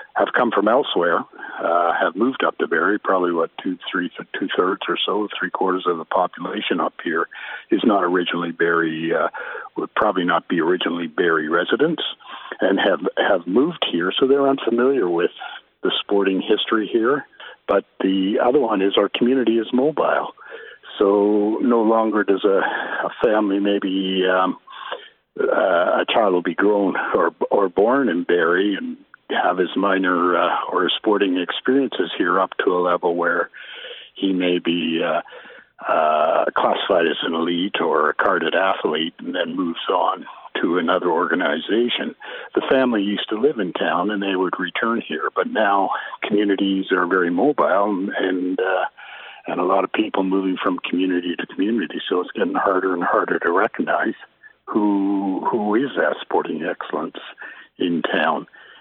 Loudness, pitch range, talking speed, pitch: -20 LUFS, 90-110 Hz, 160 wpm, 95 Hz